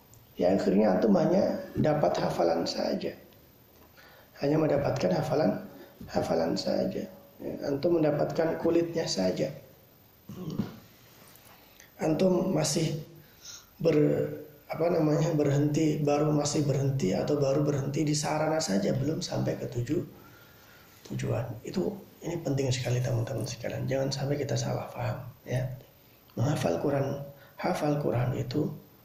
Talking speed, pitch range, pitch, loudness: 115 wpm, 125-155 Hz, 145 Hz, -29 LUFS